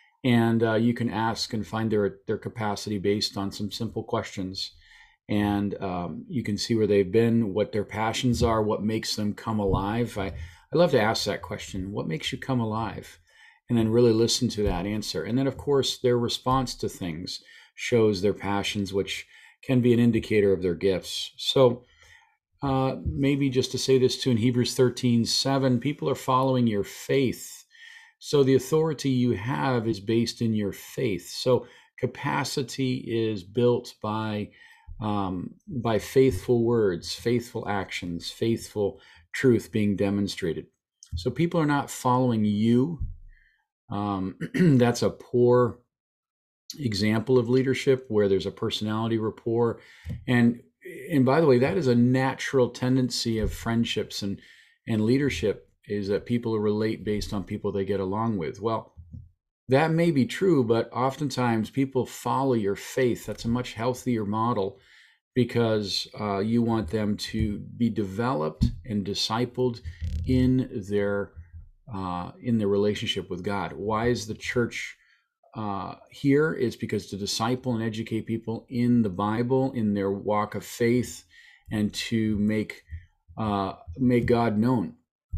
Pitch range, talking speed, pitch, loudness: 100-125 Hz, 155 wpm, 115 Hz, -26 LUFS